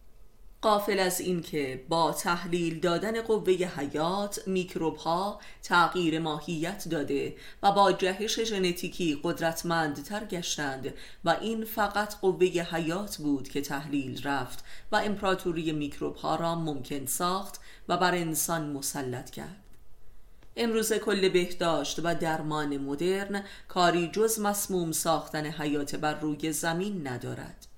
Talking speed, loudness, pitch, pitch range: 120 wpm, -29 LUFS, 170 Hz, 150-190 Hz